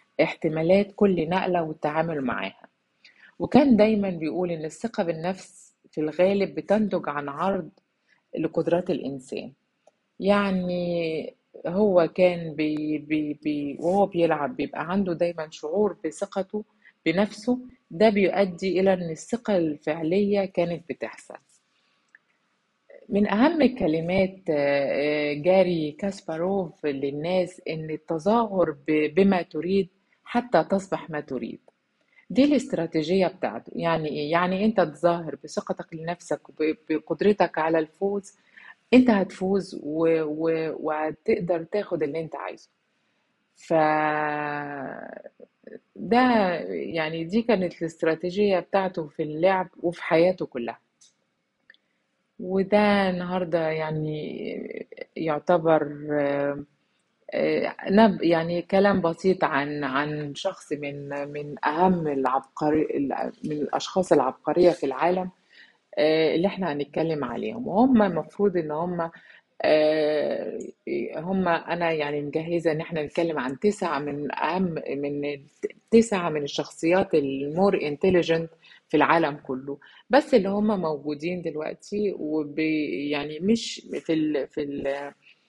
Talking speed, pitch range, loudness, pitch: 100 wpm, 155-195 Hz, -25 LUFS, 170 Hz